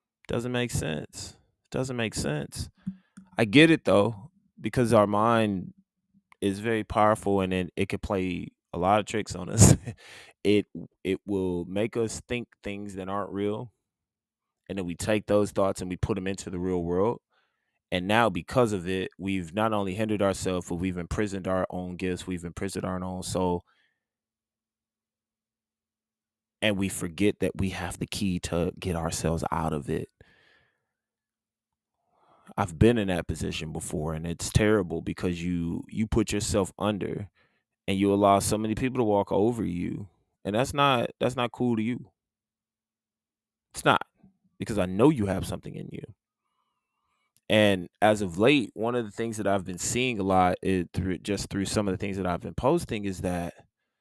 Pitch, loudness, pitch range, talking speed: 100 Hz, -27 LUFS, 90-110 Hz, 175 wpm